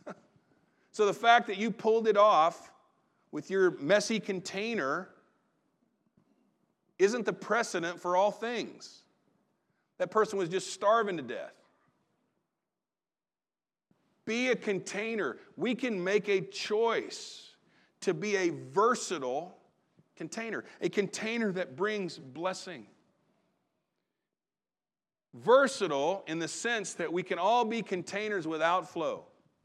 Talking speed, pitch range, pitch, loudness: 110 wpm, 185-225 Hz, 205 Hz, -30 LUFS